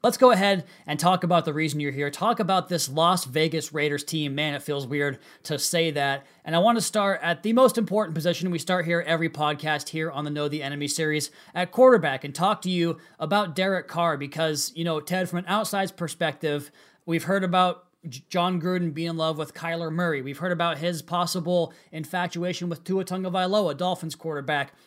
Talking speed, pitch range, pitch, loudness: 205 wpm, 155-180 Hz, 170 Hz, -25 LUFS